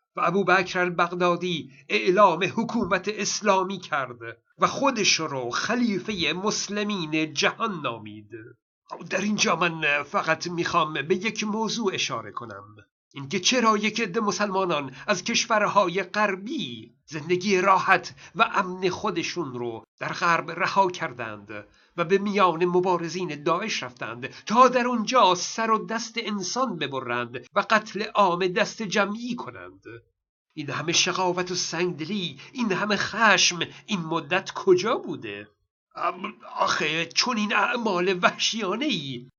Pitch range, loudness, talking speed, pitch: 160-210 Hz, -24 LUFS, 125 wpm, 185 Hz